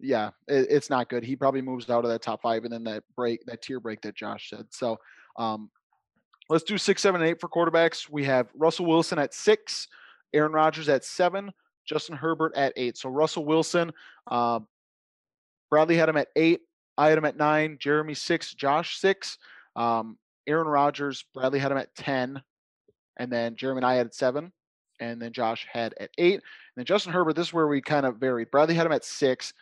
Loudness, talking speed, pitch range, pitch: -26 LUFS, 205 wpm, 120-165 Hz, 145 Hz